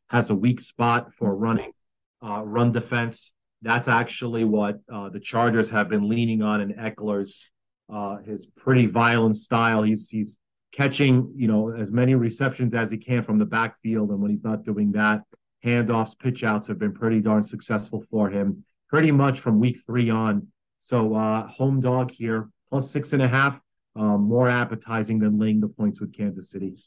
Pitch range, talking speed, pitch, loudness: 105-120 Hz, 180 wpm, 110 Hz, -23 LUFS